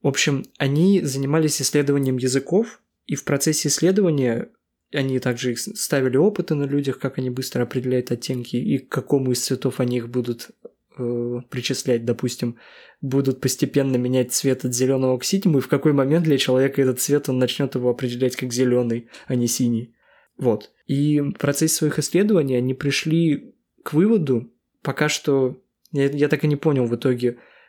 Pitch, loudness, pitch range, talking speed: 135 Hz, -21 LUFS, 125-145 Hz, 165 wpm